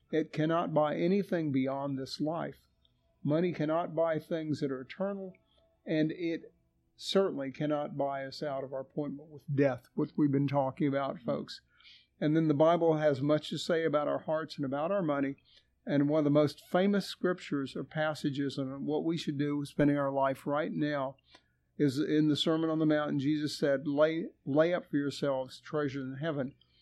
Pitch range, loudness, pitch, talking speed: 140-160 Hz, -32 LUFS, 150 Hz, 190 wpm